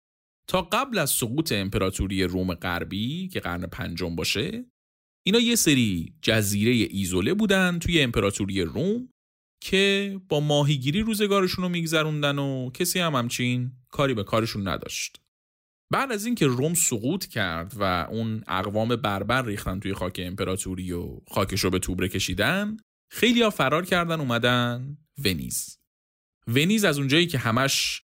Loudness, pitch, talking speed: -25 LUFS, 120 Hz, 140 wpm